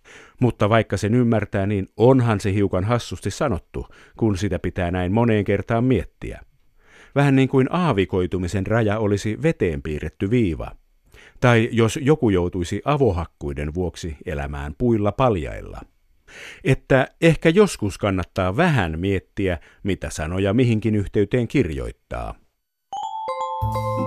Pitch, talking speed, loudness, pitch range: 105 Hz, 115 wpm, -21 LUFS, 95-130 Hz